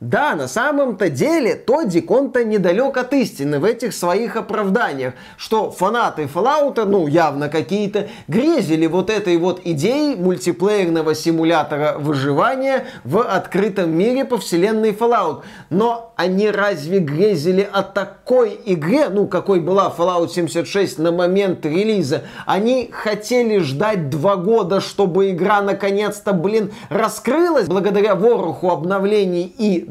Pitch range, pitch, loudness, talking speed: 175-220 Hz, 195 Hz, -18 LUFS, 125 wpm